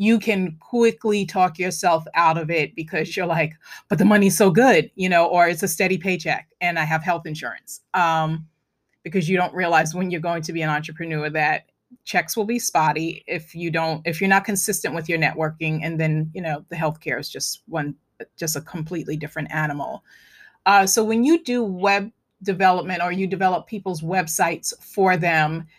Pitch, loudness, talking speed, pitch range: 175 Hz, -21 LUFS, 195 wpm, 160-195 Hz